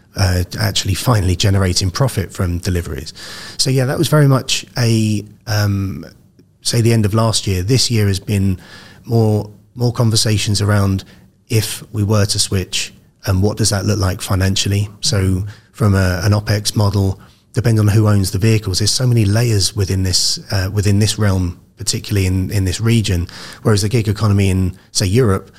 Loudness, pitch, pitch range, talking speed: -16 LUFS, 105 Hz, 95-110 Hz, 175 wpm